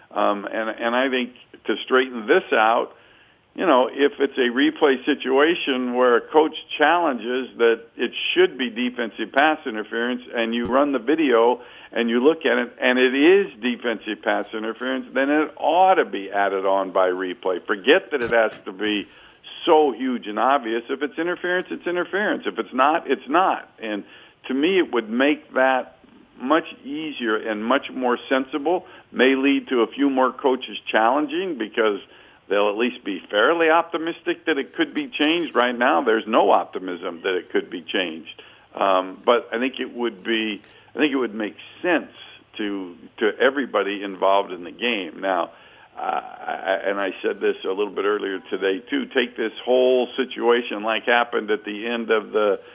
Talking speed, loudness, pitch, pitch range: 180 wpm, -21 LUFS, 130 Hz, 115-175 Hz